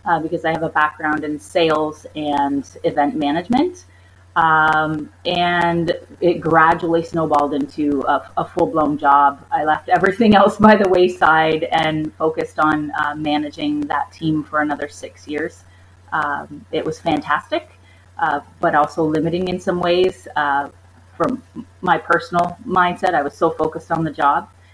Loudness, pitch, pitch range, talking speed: -18 LUFS, 155 Hz, 145-170 Hz, 155 wpm